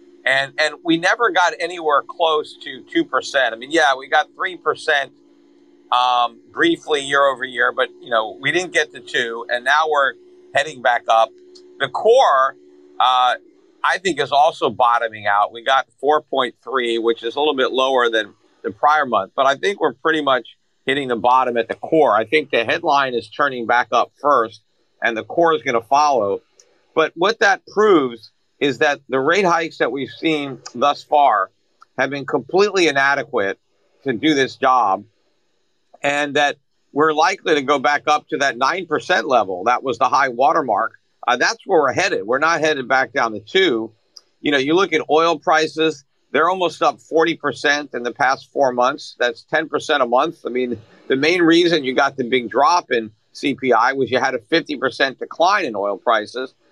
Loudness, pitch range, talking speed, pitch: -18 LUFS, 125-165 Hz, 190 wpm, 140 Hz